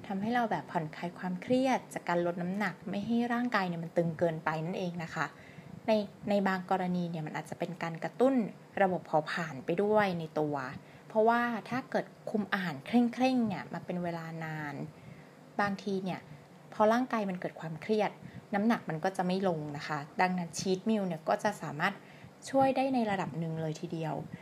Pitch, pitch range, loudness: 180 Hz, 165-210 Hz, -33 LUFS